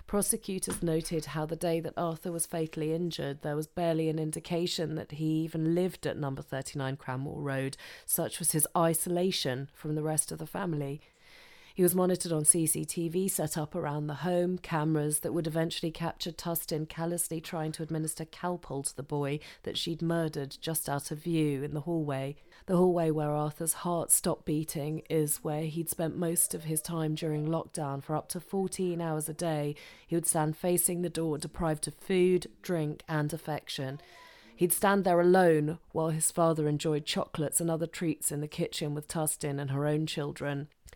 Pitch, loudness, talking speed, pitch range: 160 Hz, -31 LUFS, 185 wpm, 150-170 Hz